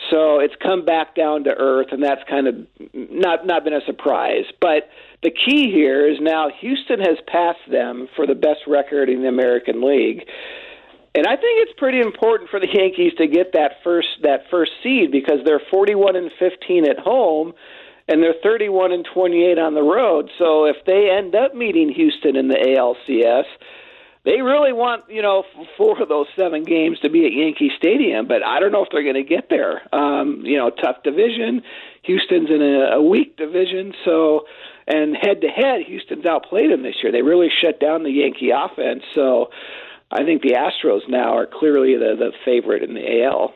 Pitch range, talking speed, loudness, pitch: 150-245 Hz, 195 wpm, -17 LUFS, 175 Hz